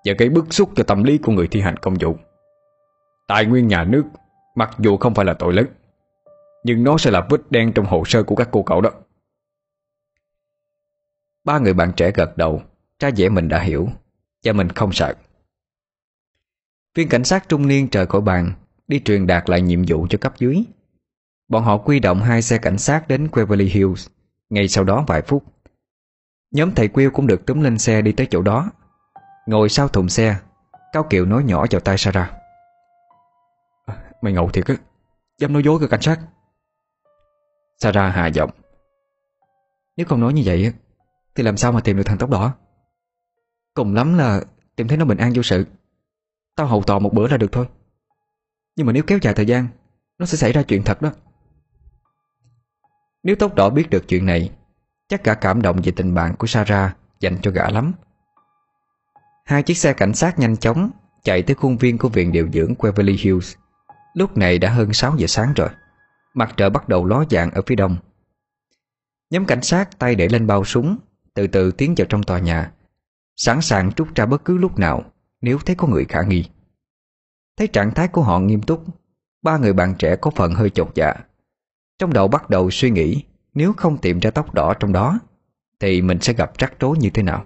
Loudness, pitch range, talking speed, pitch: -18 LUFS, 100-160 Hz, 200 wpm, 120 Hz